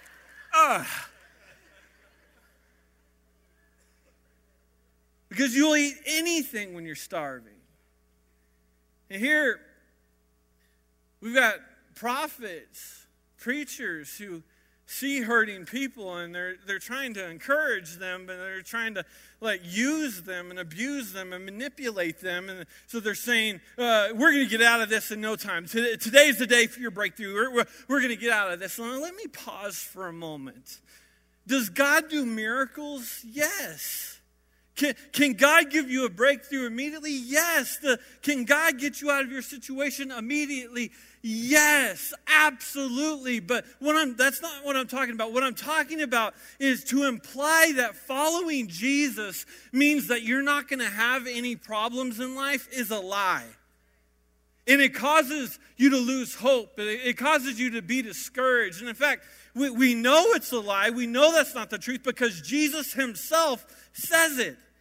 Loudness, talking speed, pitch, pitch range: -25 LUFS, 155 wpm, 245 Hz, 190-280 Hz